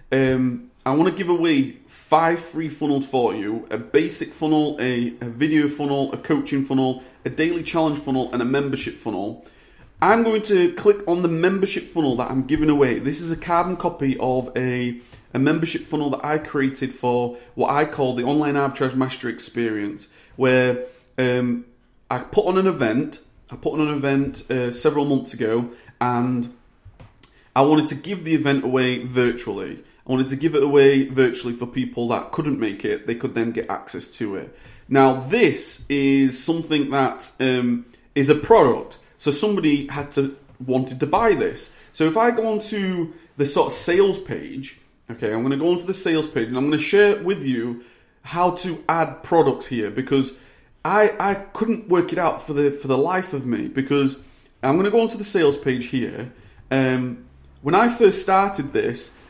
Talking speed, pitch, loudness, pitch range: 190 wpm, 140 Hz, -21 LUFS, 125-165 Hz